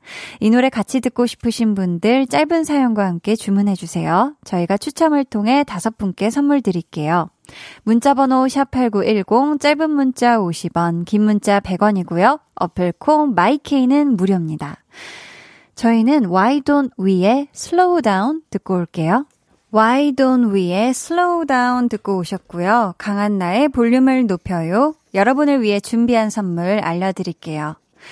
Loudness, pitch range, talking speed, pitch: -17 LUFS, 190-265 Hz, 320 characters per minute, 225 Hz